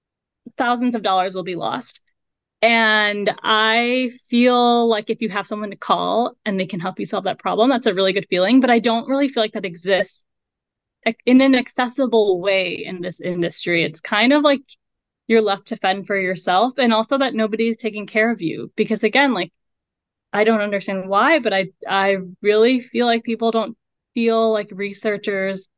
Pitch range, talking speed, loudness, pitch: 195-235 Hz, 185 wpm, -18 LUFS, 220 Hz